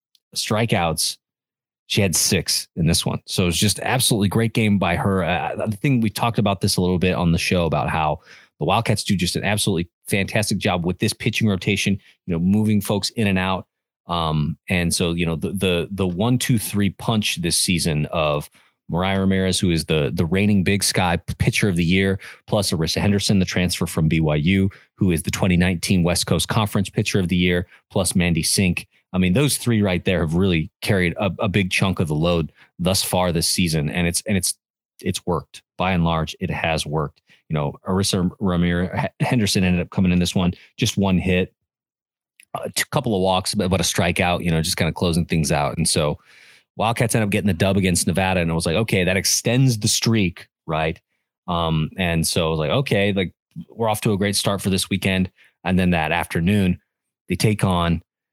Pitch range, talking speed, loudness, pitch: 85-105 Hz, 210 wpm, -20 LUFS, 95 Hz